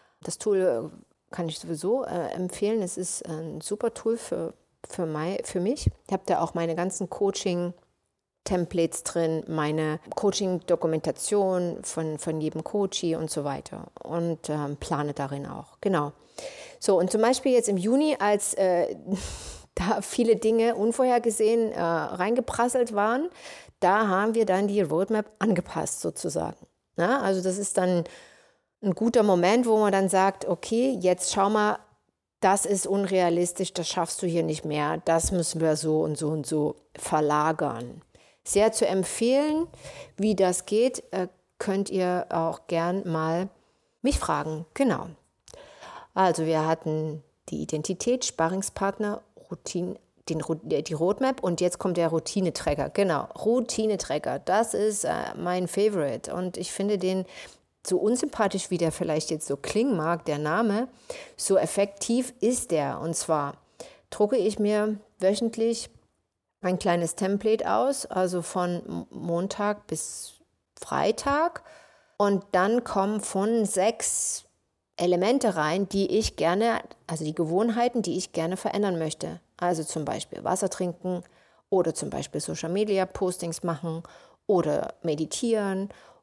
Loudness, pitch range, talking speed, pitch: -27 LUFS, 165-215 Hz, 135 wpm, 185 Hz